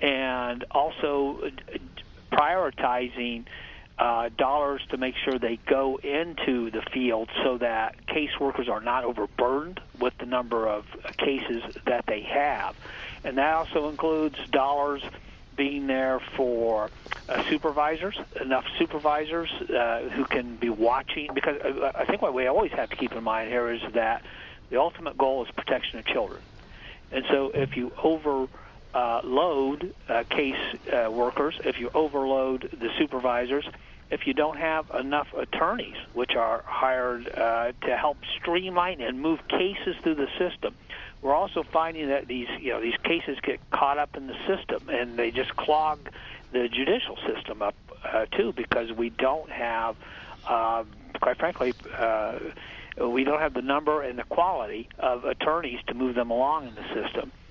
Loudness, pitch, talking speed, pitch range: -27 LUFS, 130 Hz, 160 wpm, 120-150 Hz